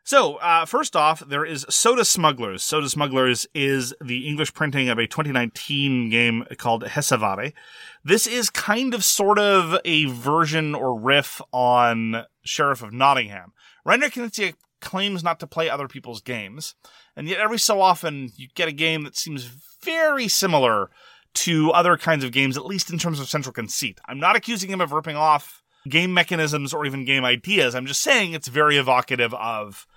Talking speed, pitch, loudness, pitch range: 175 wpm, 150 Hz, -21 LUFS, 130-175 Hz